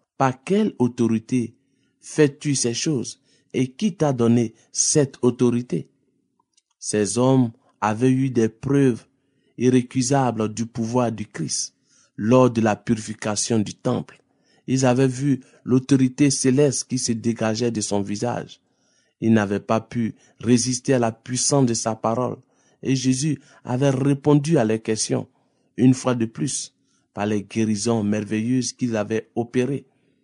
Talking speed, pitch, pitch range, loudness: 135 wpm, 125 Hz, 110-135 Hz, -22 LUFS